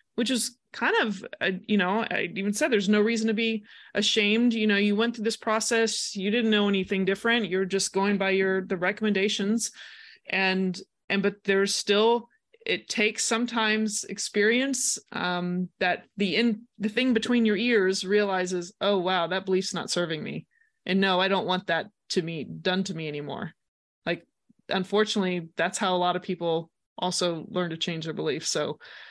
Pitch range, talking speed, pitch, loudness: 185-225 Hz, 180 wpm, 205 Hz, -26 LUFS